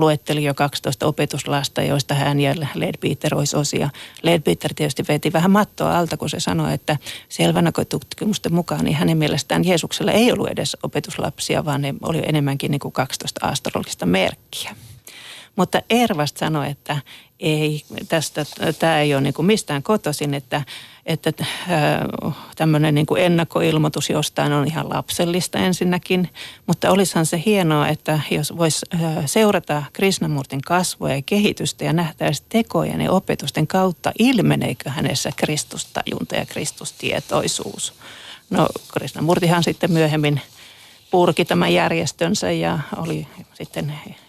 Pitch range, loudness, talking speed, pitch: 145-175 Hz, -20 LUFS, 130 wpm, 155 Hz